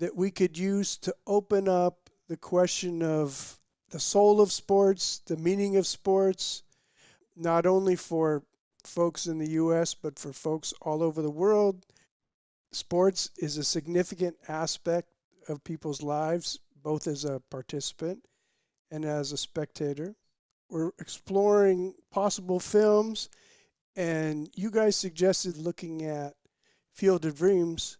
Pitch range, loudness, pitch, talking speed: 155-195 Hz, -28 LUFS, 175 Hz, 130 wpm